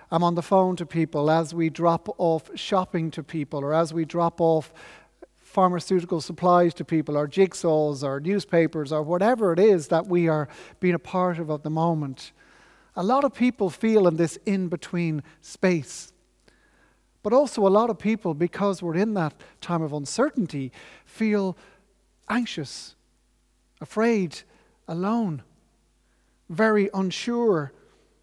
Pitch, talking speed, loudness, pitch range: 175 Hz, 145 wpm, -24 LUFS, 160-200 Hz